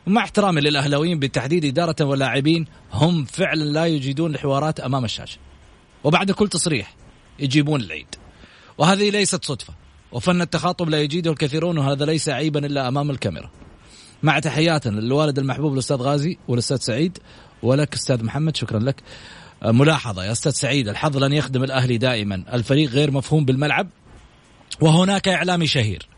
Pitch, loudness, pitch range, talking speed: 145 Hz, -20 LUFS, 125-160 Hz, 140 wpm